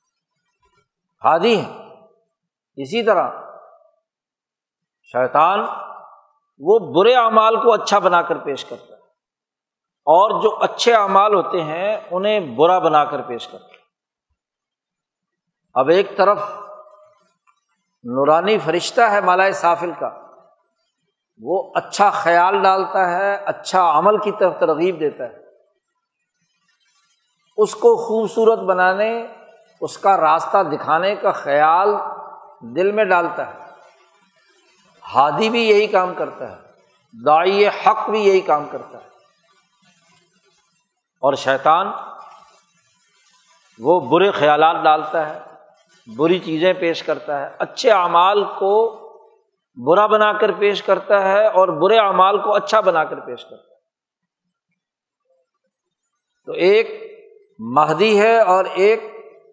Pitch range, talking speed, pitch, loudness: 175-225 Hz, 115 wpm, 200 Hz, -16 LUFS